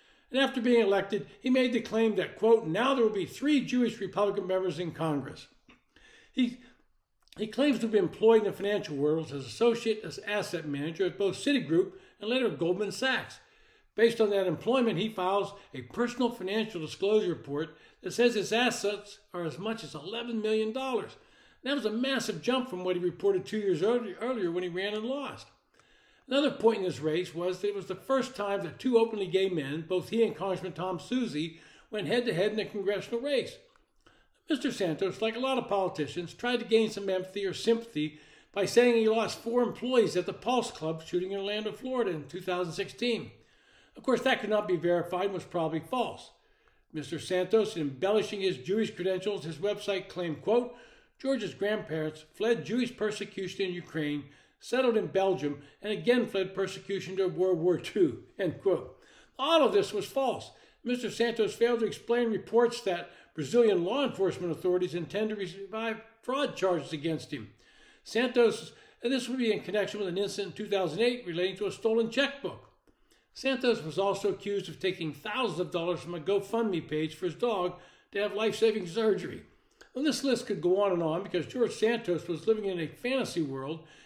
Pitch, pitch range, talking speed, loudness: 205 Hz, 180-235 Hz, 185 wpm, -30 LUFS